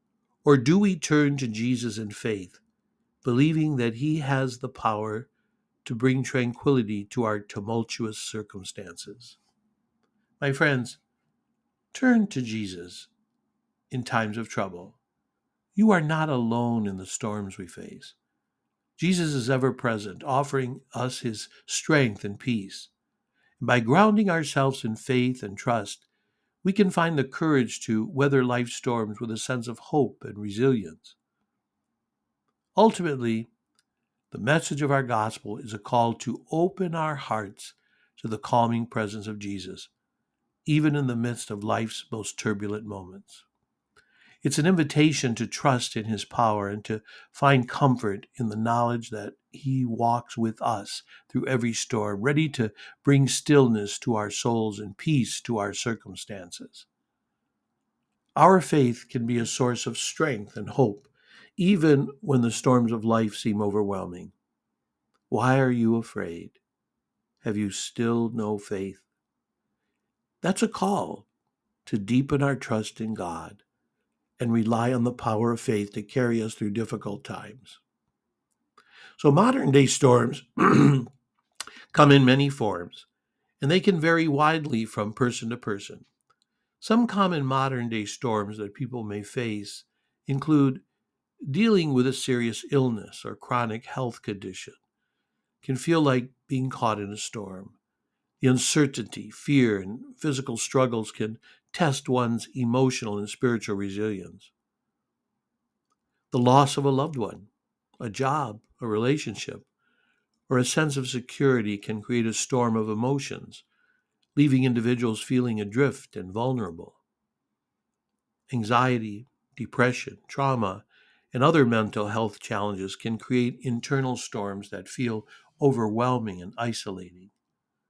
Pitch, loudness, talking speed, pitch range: 120 Hz, -25 LUFS, 135 wpm, 110-140 Hz